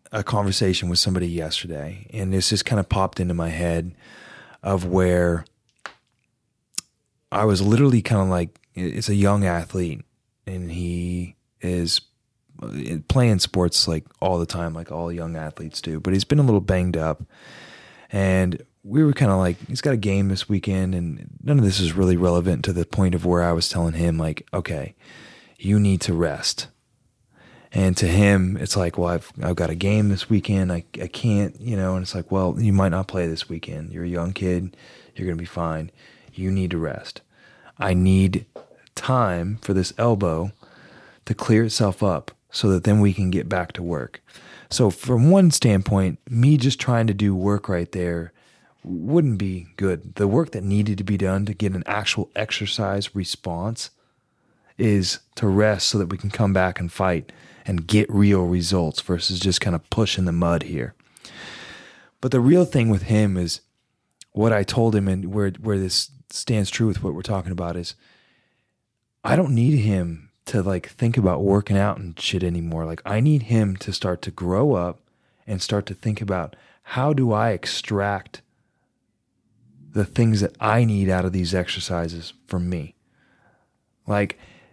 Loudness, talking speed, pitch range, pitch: -22 LUFS, 185 wpm, 90-105 Hz, 95 Hz